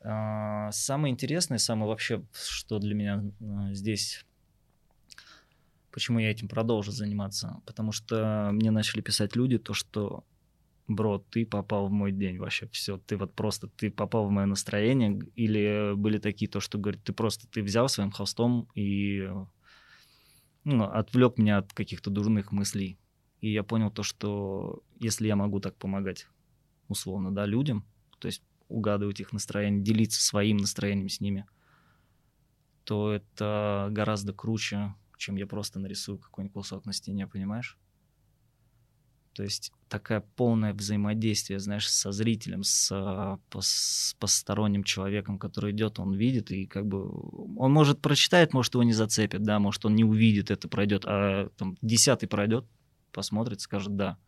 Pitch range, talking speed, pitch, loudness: 100-115 Hz, 150 wpm, 105 Hz, -29 LUFS